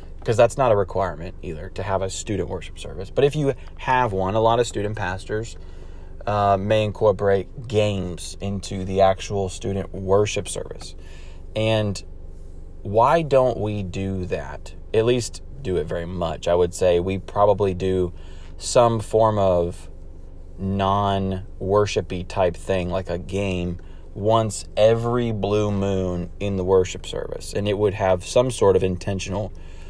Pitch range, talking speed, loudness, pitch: 85-105 Hz, 150 wpm, -22 LUFS, 95 Hz